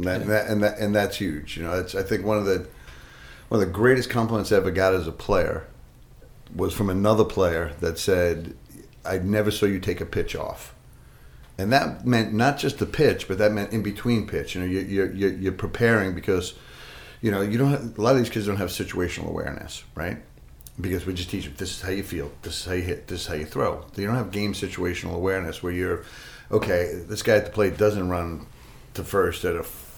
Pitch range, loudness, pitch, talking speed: 90-105 Hz, -25 LUFS, 95 Hz, 235 wpm